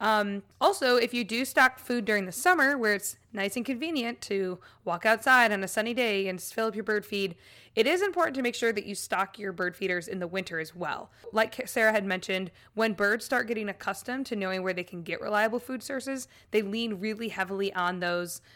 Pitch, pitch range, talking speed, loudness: 215 Hz, 190-245 Hz, 225 wpm, -28 LUFS